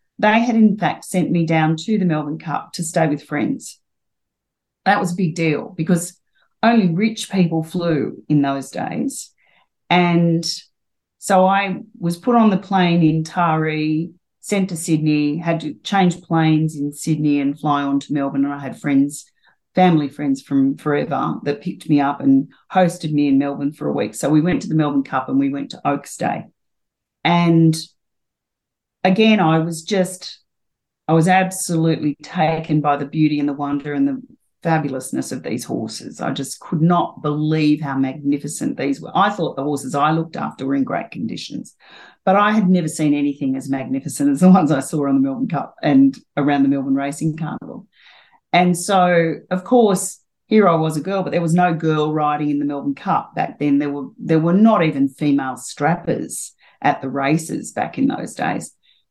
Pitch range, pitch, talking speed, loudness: 145-185 Hz, 160 Hz, 190 wpm, -19 LUFS